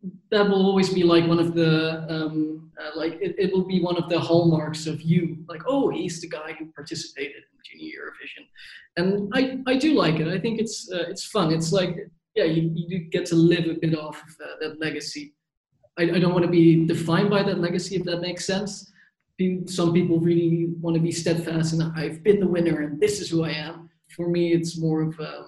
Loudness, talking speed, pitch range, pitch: -23 LUFS, 225 wpm, 160-185 Hz, 170 Hz